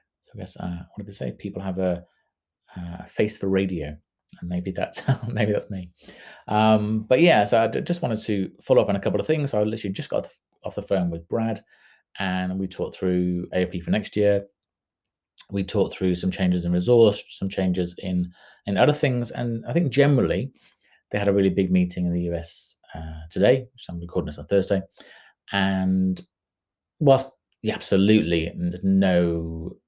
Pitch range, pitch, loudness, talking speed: 90-105 Hz, 95 Hz, -24 LUFS, 185 wpm